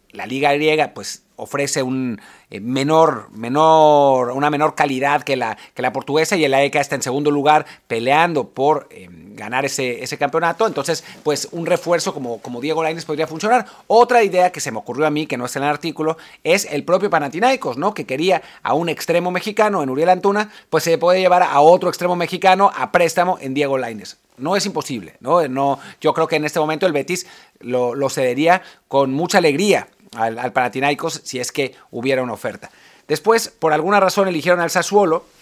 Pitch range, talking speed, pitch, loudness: 140-180 Hz, 200 wpm, 155 Hz, -18 LUFS